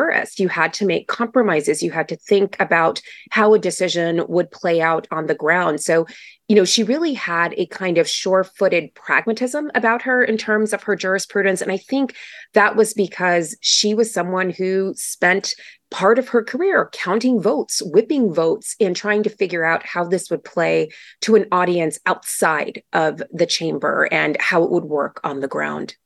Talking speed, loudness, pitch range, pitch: 185 wpm, -18 LUFS, 170-220 Hz, 190 Hz